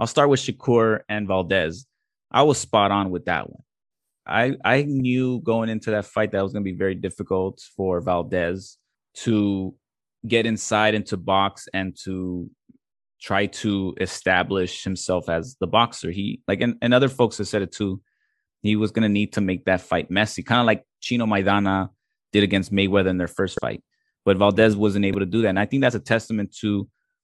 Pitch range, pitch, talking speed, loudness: 95-115 Hz, 100 Hz, 200 wpm, -22 LUFS